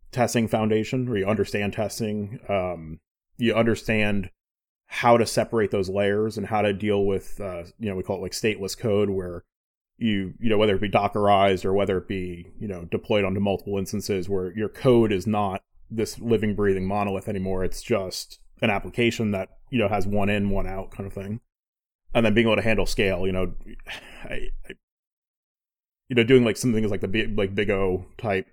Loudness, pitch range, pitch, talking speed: -24 LUFS, 95-110 Hz, 100 Hz, 200 wpm